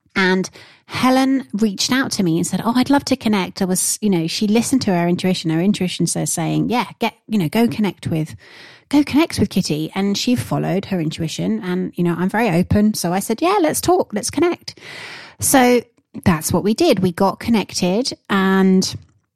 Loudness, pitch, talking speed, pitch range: -18 LUFS, 195 Hz, 200 wpm, 175-240 Hz